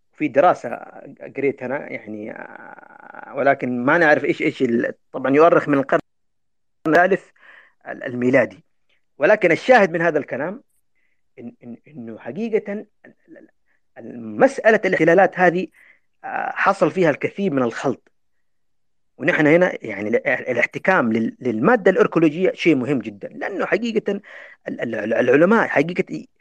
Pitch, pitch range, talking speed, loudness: 185 Hz, 155-250 Hz, 105 wpm, -19 LUFS